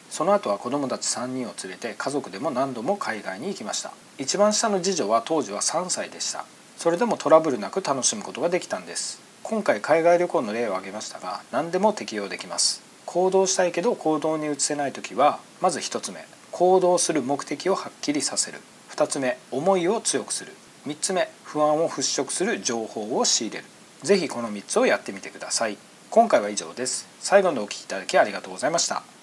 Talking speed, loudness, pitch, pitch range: 405 characters per minute, -24 LUFS, 160 Hz, 125-190 Hz